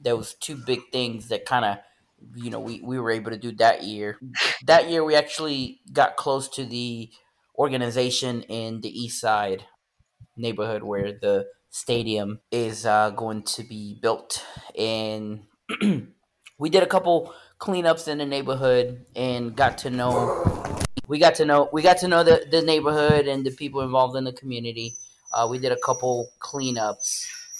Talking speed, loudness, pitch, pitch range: 170 wpm, -24 LUFS, 125 Hz, 115-145 Hz